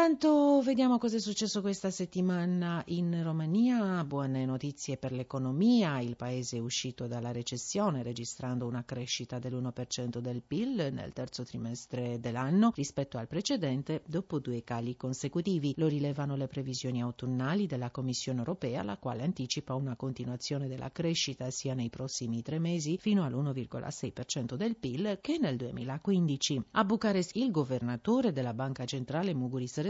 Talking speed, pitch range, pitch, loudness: 140 wpm, 125-175 Hz, 135 Hz, -33 LUFS